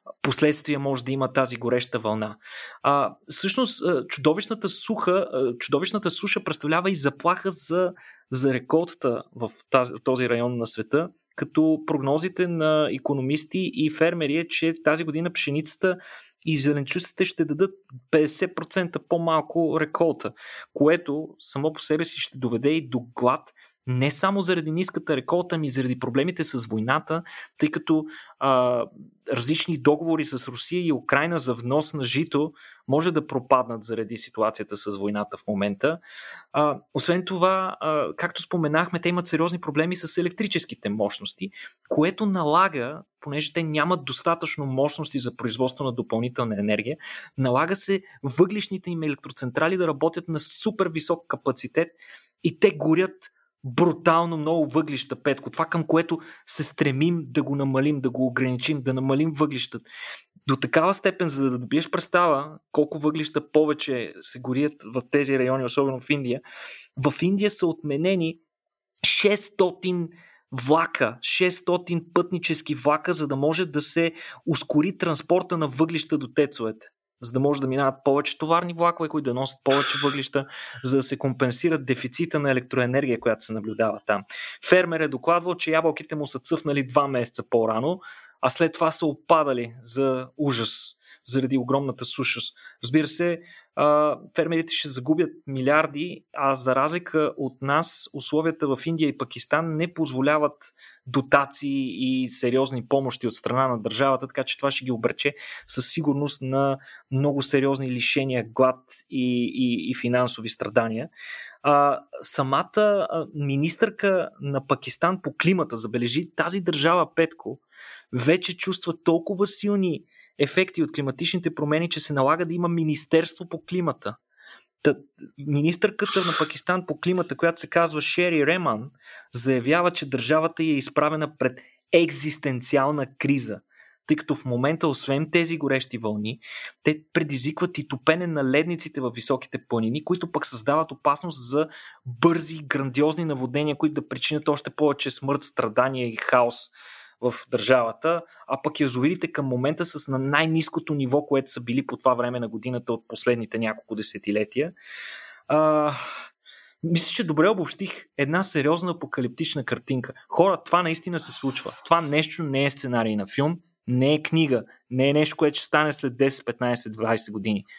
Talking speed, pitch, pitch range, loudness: 145 wpm, 150 Hz, 130-165 Hz, -24 LUFS